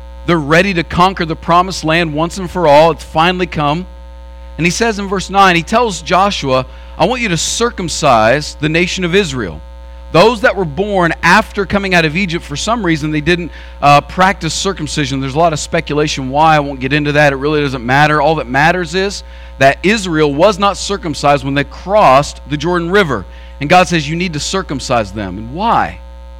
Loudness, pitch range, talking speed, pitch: -12 LUFS, 140-185 Hz, 200 wpm, 160 Hz